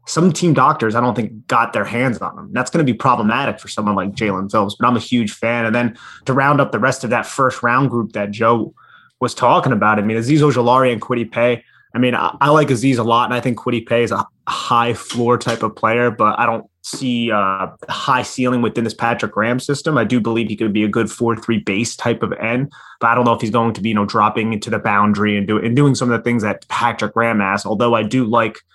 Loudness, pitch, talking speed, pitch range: -17 LUFS, 115 Hz, 265 wpm, 110-120 Hz